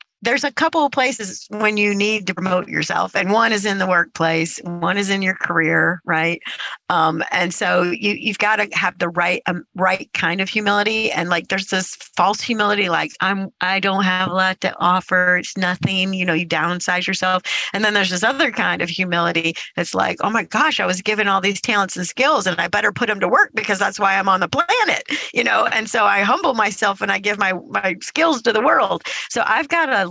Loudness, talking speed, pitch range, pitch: -18 LUFS, 230 wpm, 180-215 Hz, 195 Hz